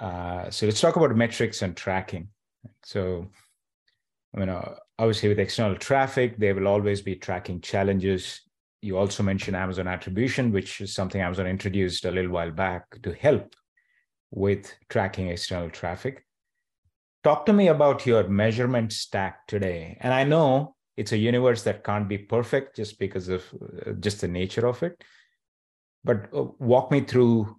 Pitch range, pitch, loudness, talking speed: 95-120 Hz, 100 Hz, -25 LUFS, 160 wpm